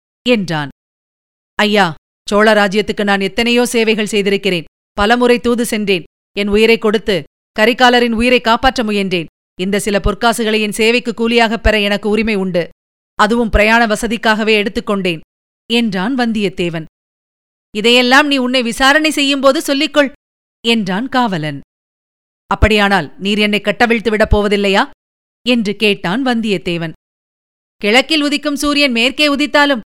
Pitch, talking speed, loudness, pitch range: 220 Hz, 110 wpm, -13 LUFS, 205-245 Hz